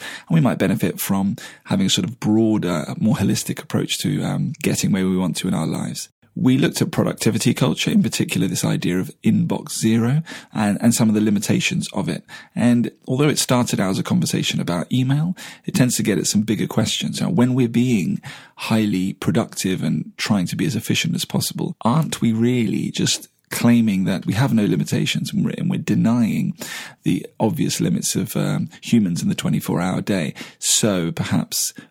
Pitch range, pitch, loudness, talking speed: 110-170 Hz, 120 Hz, -20 LUFS, 190 wpm